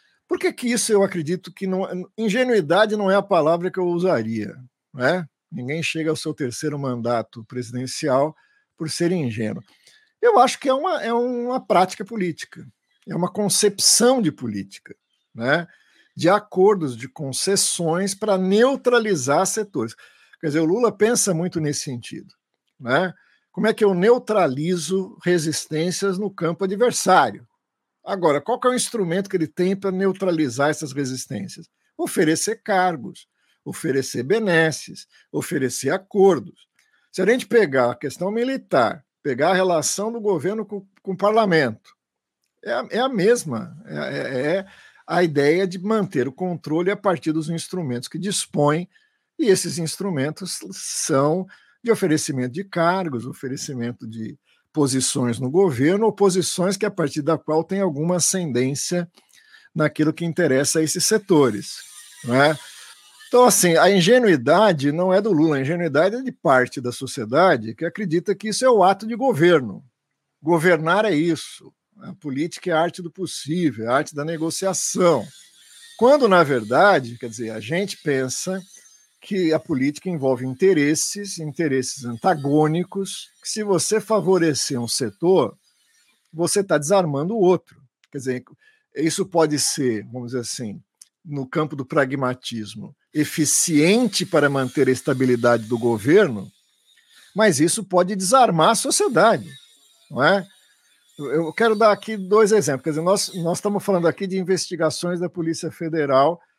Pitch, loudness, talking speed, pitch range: 175 Hz, -20 LUFS, 145 wpm, 145-200 Hz